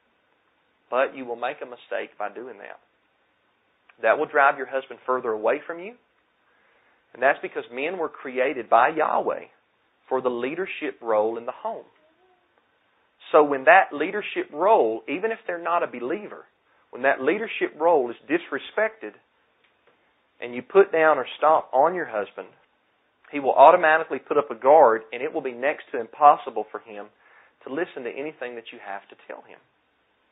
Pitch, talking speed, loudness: 135 Hz, 170 wpm, -23 LUFS